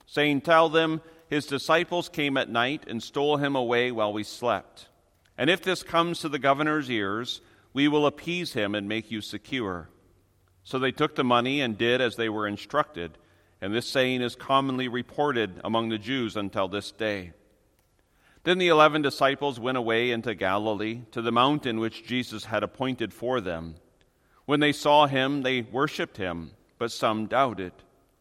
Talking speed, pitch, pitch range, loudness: 170 wpm, 120 Hz, 105-145 Hz, -26 LUFS